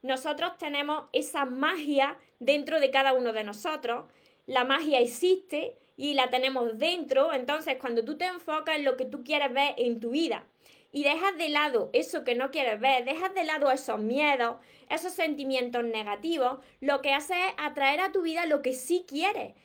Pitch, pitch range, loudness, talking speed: 285 Hz, 260-315 Hz, -28 LUFS, 185 wpm